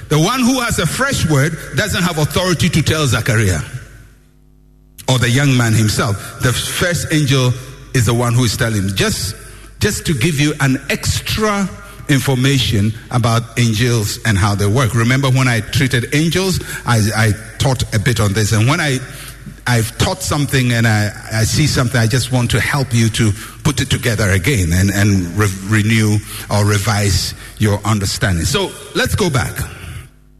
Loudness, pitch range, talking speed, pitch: -15 LUFS, 110-135 Hz, 170 wpm, 120 Hz